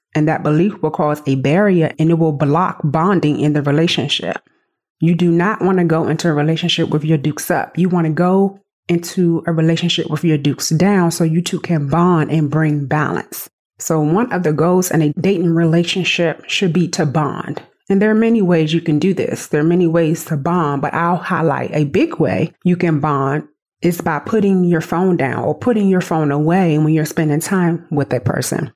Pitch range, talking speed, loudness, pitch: 155-175 Hz, 210 wpm, -16 LUFS, 165 Hz